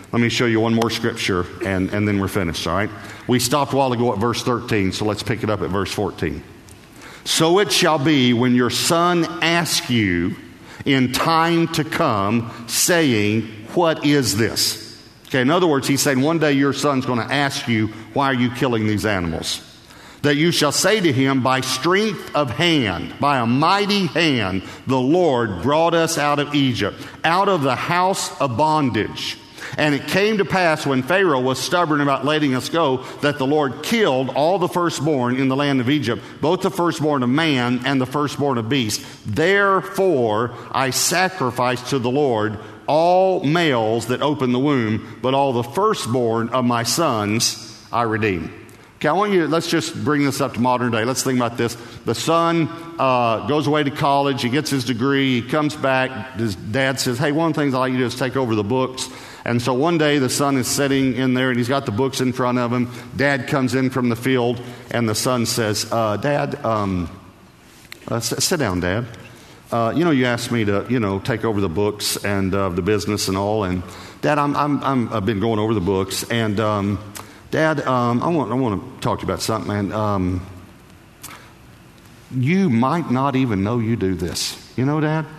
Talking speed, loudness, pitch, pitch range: 205 wpm, -19 LUFS, 130 Hz, 110-145 Hz